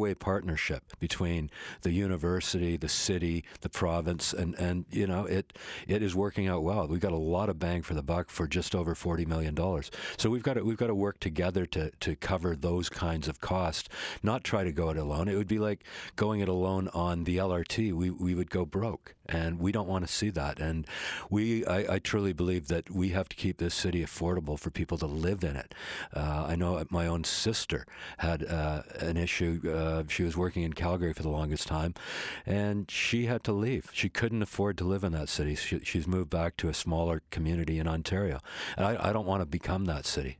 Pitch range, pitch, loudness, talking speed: 85-95 Hz, 90 Hz, -32 LUFS, 220 wpm